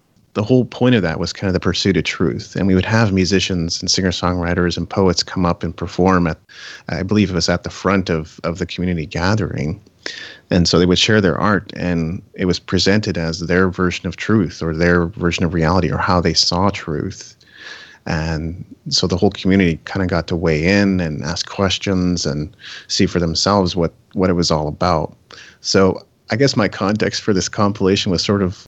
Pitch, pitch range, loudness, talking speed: 90 Hz, 85-95 Hz, -17 LUFS, 205 wpm